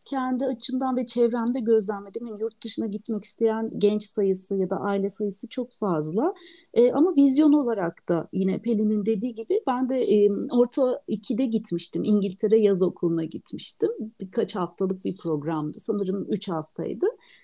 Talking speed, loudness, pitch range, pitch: 150 wpm, -25 LUFS, 195-250 Hz, 220 Hz